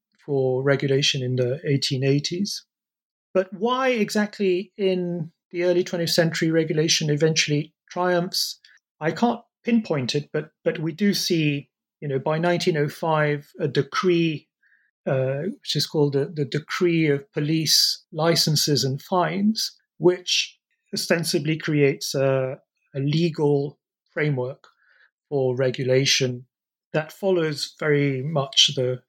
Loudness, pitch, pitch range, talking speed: -23 LUFS, 155 Hz, 140-180 Hz, 120 wpm